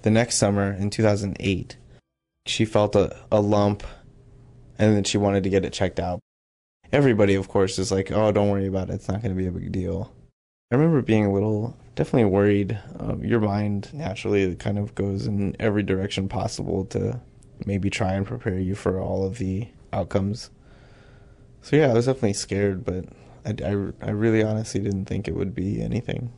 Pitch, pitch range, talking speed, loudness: 100 Hz, 95-115 Hz, 190 wpm, -24 LUFS